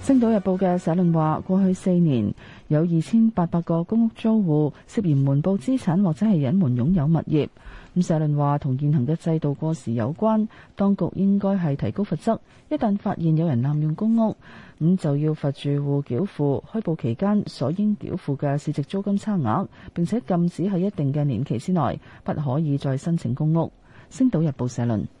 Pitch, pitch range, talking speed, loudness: 165 Hz, 145-195 Hz, 290 characters per minute, -23 LUFS